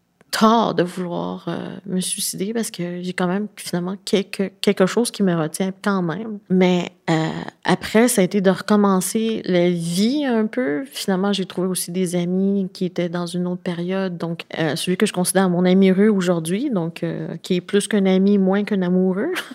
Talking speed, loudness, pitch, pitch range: 195 wpm, -20 LUFS, 185 Hz, 180-200 Hz